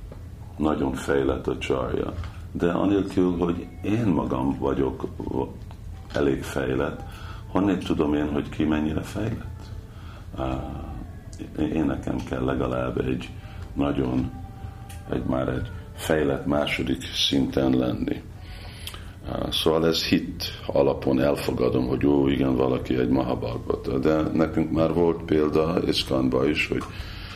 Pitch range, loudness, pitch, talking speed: 65-95 Hz, -25 LUFS, 80 Hz, 110 wpm